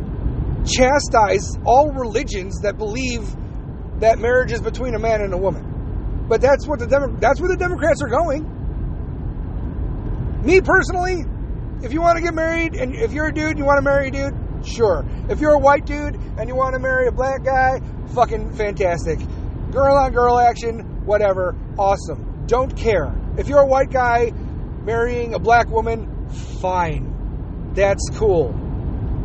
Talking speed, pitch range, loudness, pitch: 165 wpm, 225-285 Hz, -19 LUFS, 260 Hz